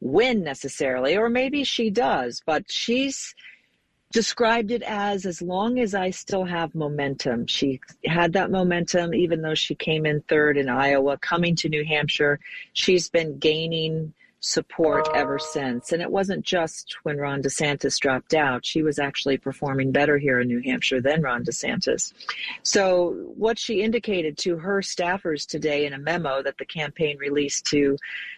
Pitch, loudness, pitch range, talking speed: 160 Hz, -24 LUFS, 145-185 Hz, 165 wpm